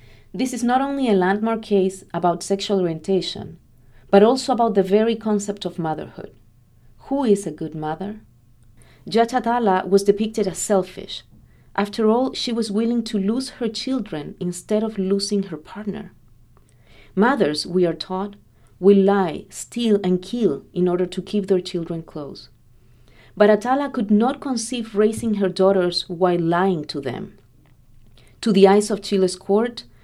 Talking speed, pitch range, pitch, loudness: 150 wpm, 165-215 Hz, 195 Hz, -21 LUFS